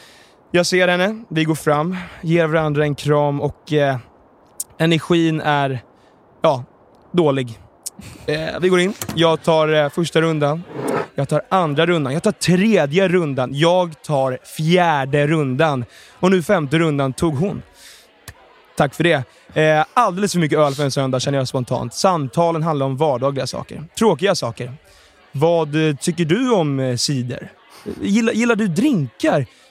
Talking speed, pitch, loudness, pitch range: 150 wpm, 160 Hz, -18 LUFS, 140-175 Hz